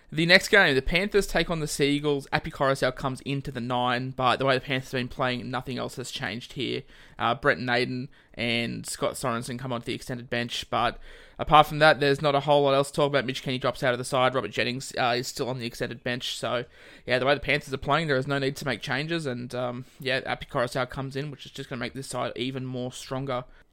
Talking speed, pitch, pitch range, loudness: 255 wpm, 130 Hz, 125-140 Hz, -26 LUFS